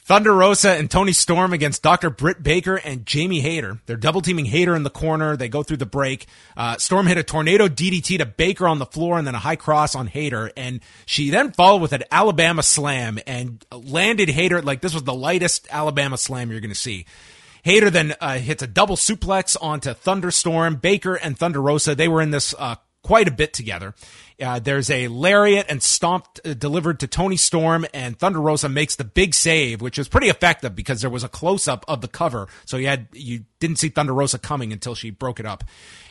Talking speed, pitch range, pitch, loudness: 220 wpm, 130-175 Hz, 150 Hz, -19 LUFS